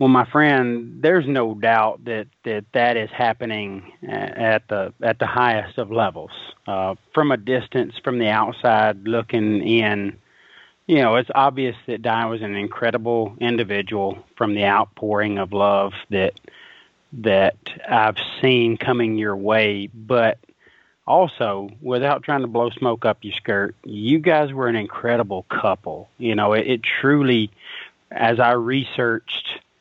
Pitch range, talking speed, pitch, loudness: 105-125 Hz, 145 wpm, 115 Hz, -20 LUFS